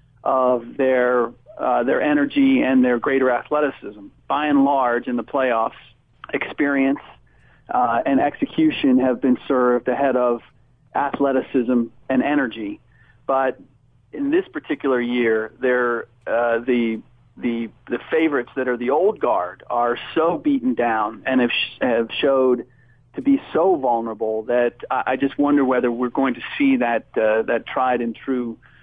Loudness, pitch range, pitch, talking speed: -20 LUFS, 120-140 Hz, 125 Hz, 150 wpm